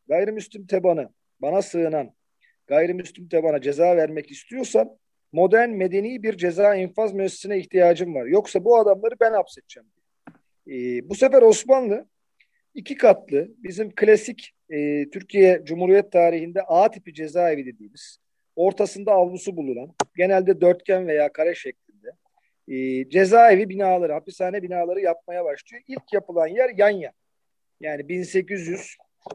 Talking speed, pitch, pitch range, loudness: 125 wpm, 190 Hz, 170-215 Hz, -20 LUFS